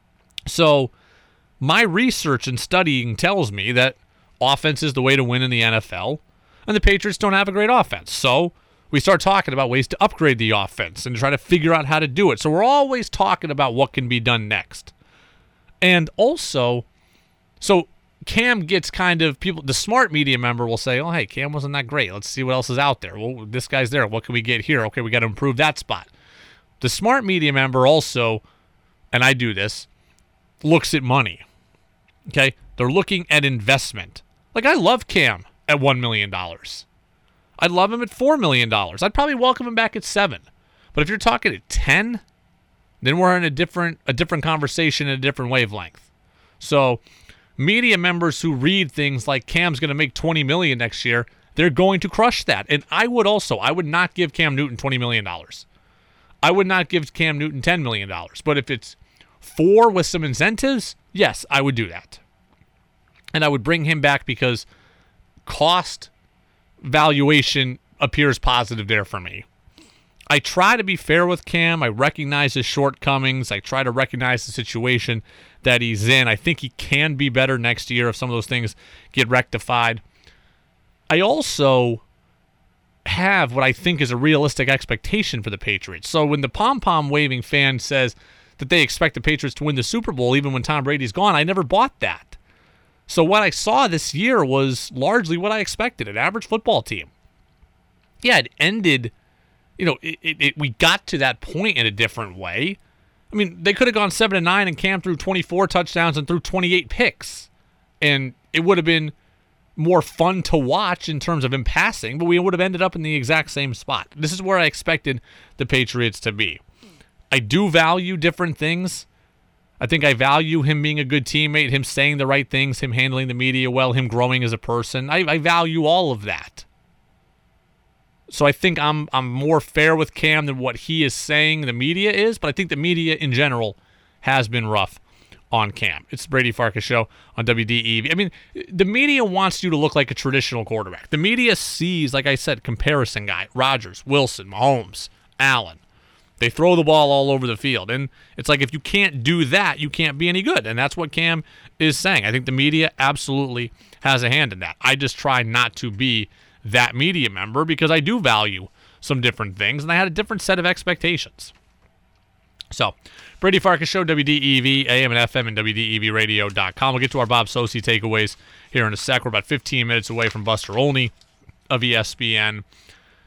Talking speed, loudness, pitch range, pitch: 195 wpm, -19 LUFS, 120-170 Hz, 140 Hz